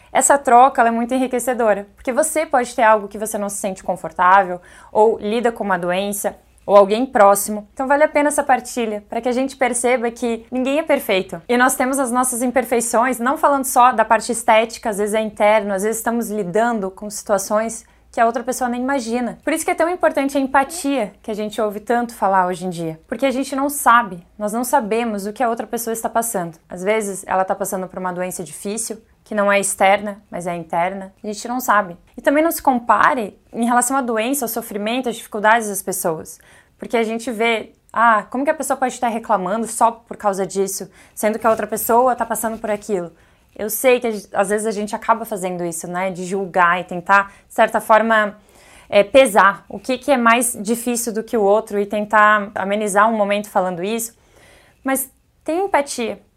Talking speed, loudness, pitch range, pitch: 215 wpm, -18 LUFS, 205-245 Hz, 225 Hz